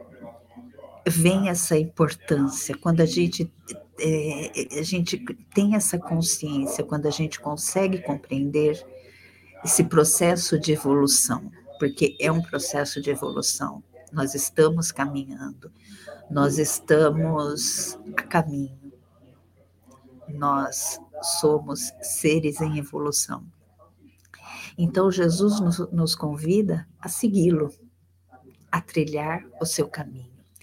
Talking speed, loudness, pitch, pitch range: 100 wpm, -24 LUFS, 155 Hz, 140-170 Hz